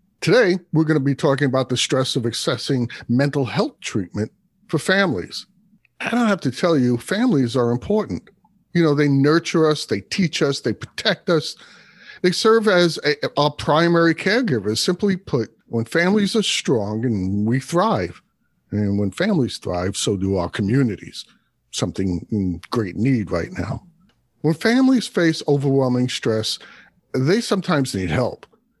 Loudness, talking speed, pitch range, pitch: -20 LUFS, 155 wpm, 120-185 Hz, 145 Hz